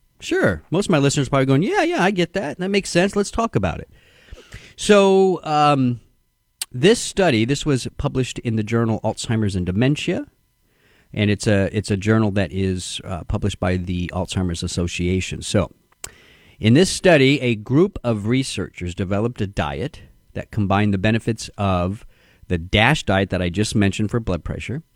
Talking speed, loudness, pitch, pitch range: 175 wpm, -20 LUFS, 110 Hz, 95-145 Hz